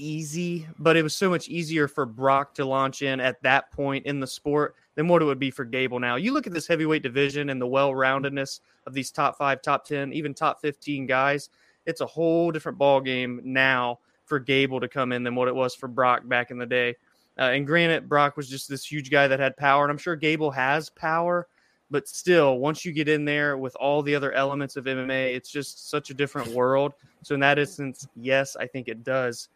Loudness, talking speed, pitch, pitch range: -25 LUFS, 230 wpm, 140 Hz, 130-150 Hz